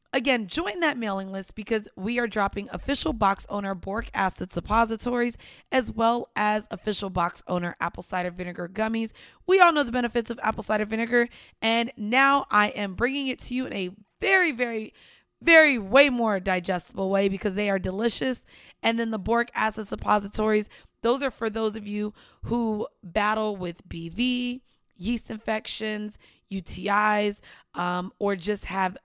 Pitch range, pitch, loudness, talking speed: 195-240 Hz, 215 Hz, -25 LUFS, 160 wpm